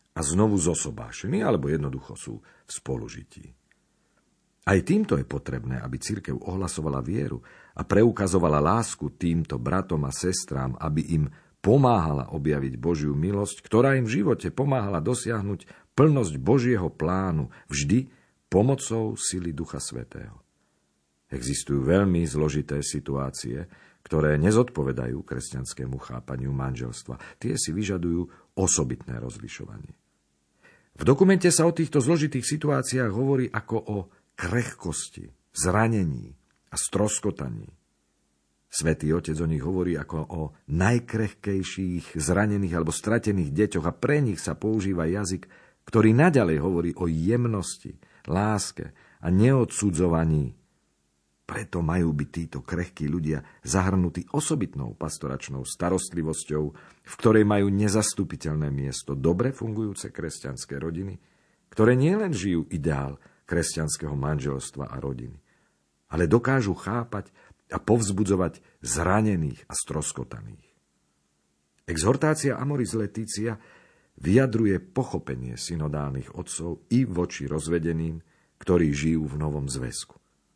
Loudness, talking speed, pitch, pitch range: -26 LUFS, 110 wpm, 85 Hz, 75-105 Hz